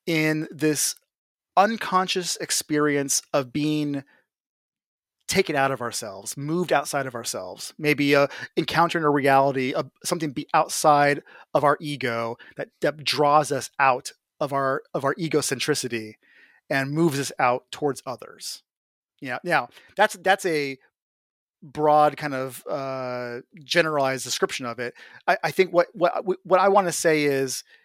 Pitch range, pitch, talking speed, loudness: 135-165 Hz, 145 Hz, 145 wpm, -23 LUFS